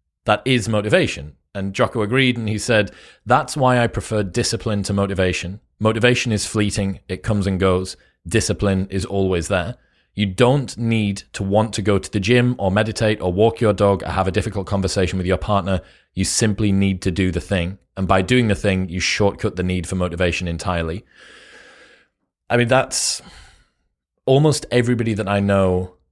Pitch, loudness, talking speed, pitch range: 100 Hz, -19 LUFS, 180 wpm, 95-110 Hz